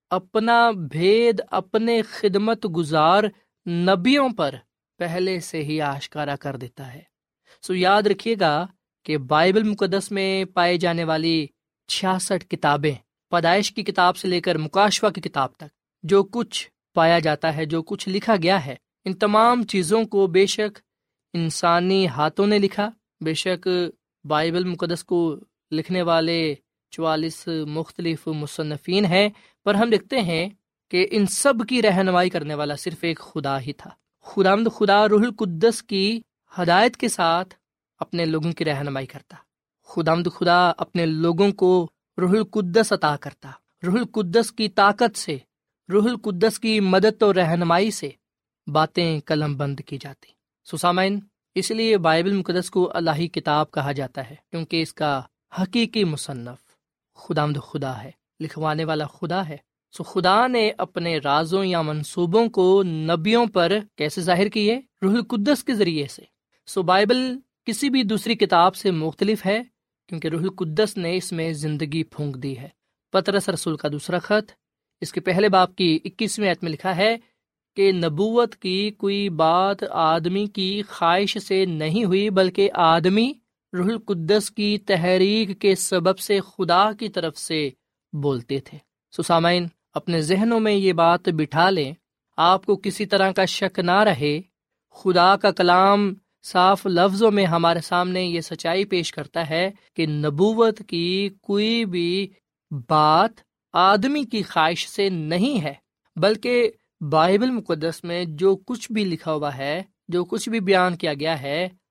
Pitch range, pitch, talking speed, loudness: 160-205 Hz, 180 Hz, 150 wpm, -21 LUFS